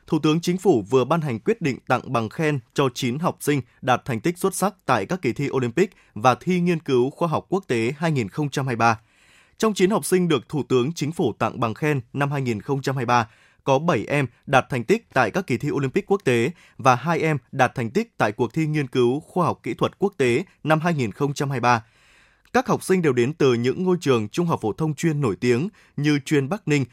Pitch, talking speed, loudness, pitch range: 140 Hz, 225 wpm, -22 LUFS, 125-165 Hz